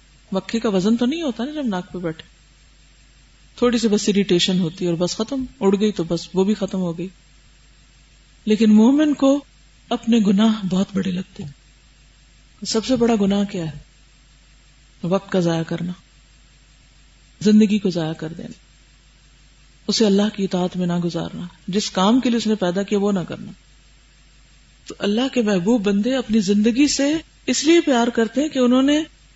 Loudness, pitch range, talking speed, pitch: -19 LUFS, 170-230 Hz, 175 wpm, 200 Hz